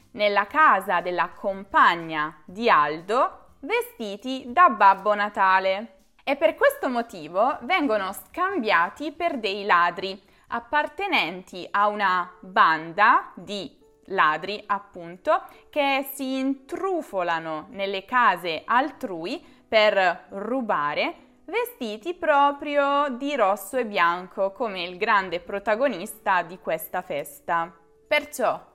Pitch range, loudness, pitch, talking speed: 185-280 Hz, -23 LUFS, 210 Hz, 100 wpm